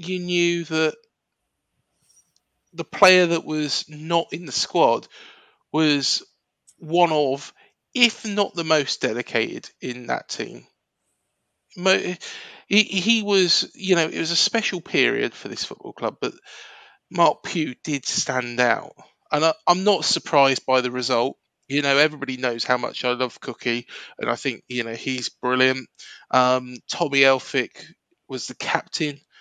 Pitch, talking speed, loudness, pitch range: 150 Hz, 145 wpm, -22 LUFS, 130-175 Hz